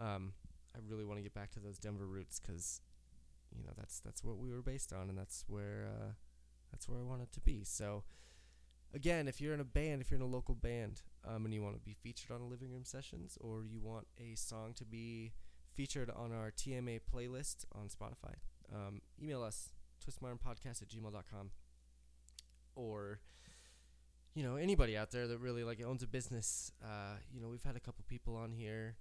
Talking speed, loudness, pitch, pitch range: 200 wpm, -46 LUFS, 110 Hz, 95-120 Hz